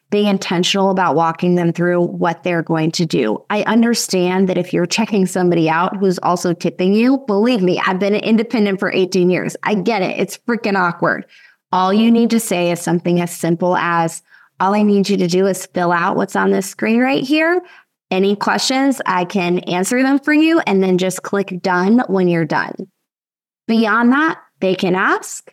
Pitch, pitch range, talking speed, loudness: 190 Hz, 175-220 Hz, 195 wpm, -16 LUFS